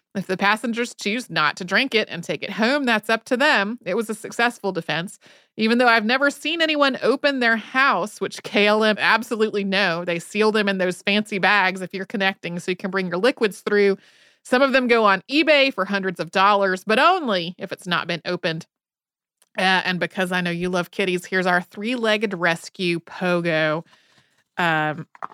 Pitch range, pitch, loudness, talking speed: 180-230 Hz, 200 Hz, -20 LUFS, 195 wpm